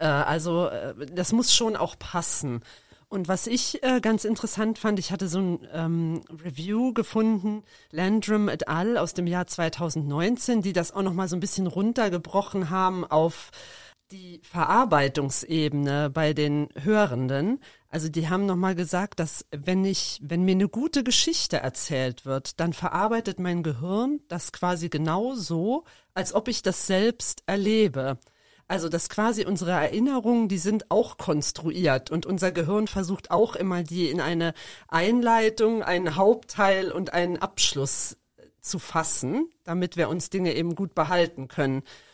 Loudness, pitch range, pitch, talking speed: -25 LUFS, 160-210 Hz, 180 Hz, 145 wpm